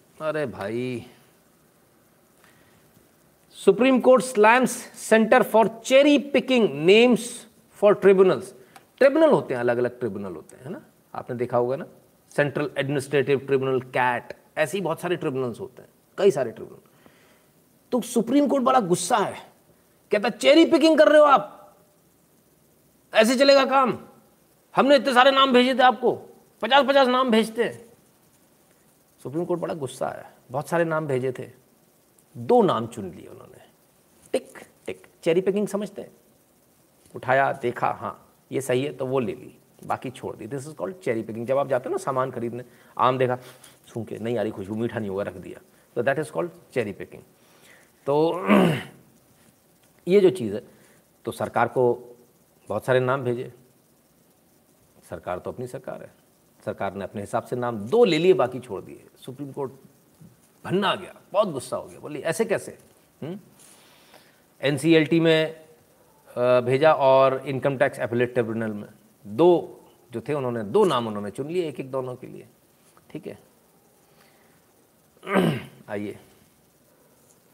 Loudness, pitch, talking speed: -22 LUFS, 145 Hz, 150 wpm